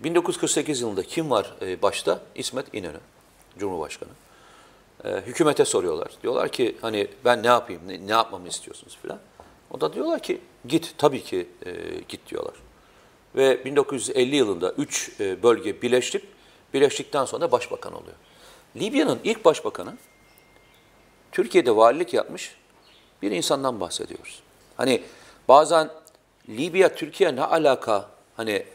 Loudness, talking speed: -23 LUFS, 115 wpm